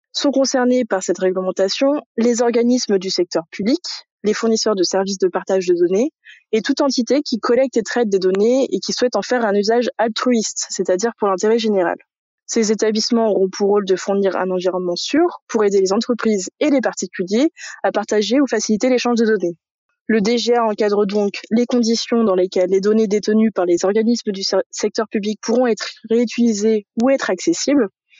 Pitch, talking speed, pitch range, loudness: 220 Hz, 185 wpm, 195-245 Hz, -18 LUFS